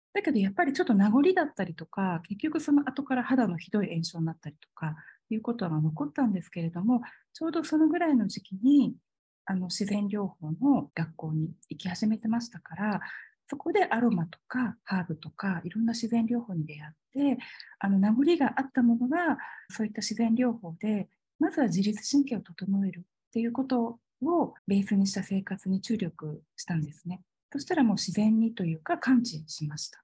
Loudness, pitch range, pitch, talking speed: -29 LUFS, 180-255 Hz, 210 Hz, 380 characters per minute